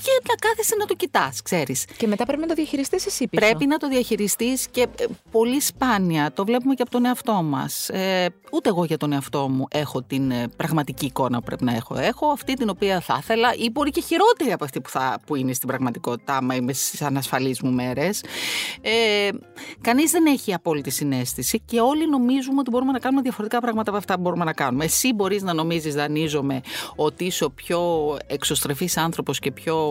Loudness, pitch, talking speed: -22 LUFS, 200 Hz, 195 wpm